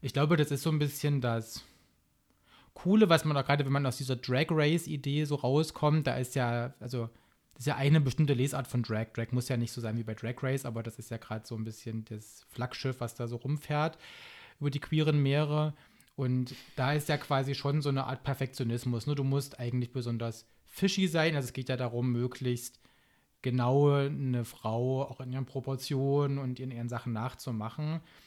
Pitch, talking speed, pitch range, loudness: 135 Hz, 205 wpm, 120-145 Hz, -32 LUFS